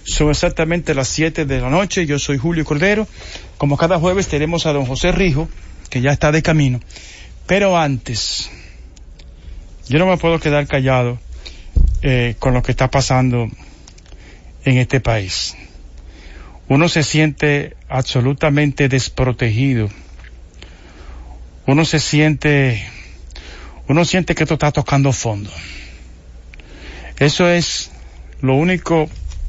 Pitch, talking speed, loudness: 130 Hz, 120 wpm, -16 LUFS